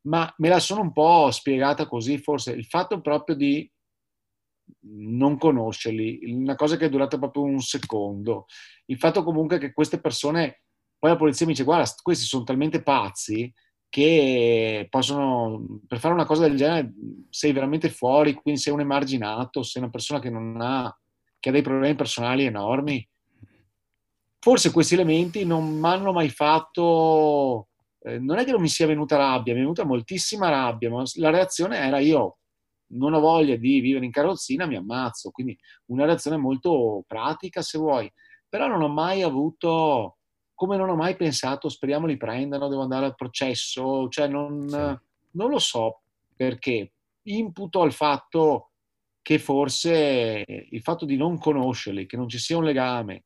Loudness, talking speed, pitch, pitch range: -23 LUFS, 165 wpm, 140 Hz, 125-160 Hz